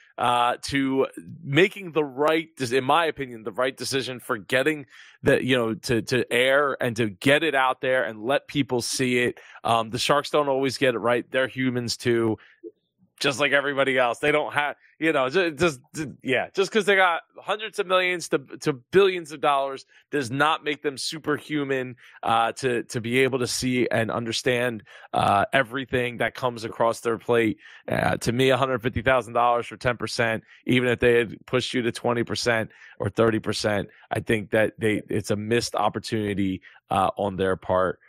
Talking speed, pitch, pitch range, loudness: 190 wpm, 130 Hz, 115-145 Hz, -24 LUFS